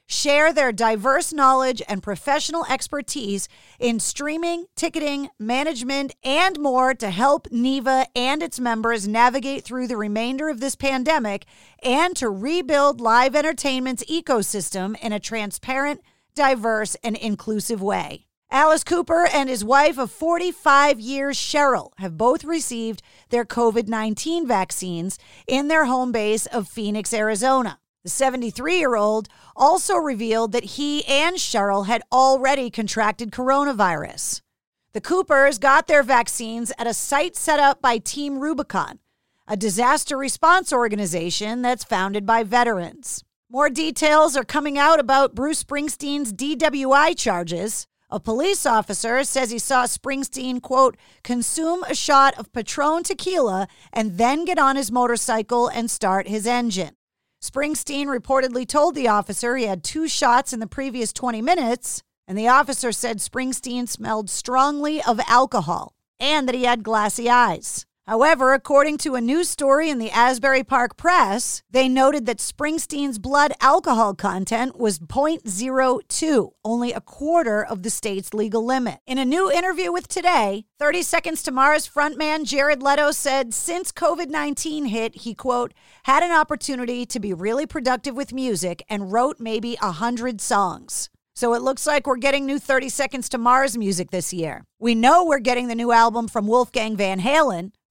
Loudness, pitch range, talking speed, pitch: -21 LUFS, 225-290 Hz, 150 wpm, 260 Hz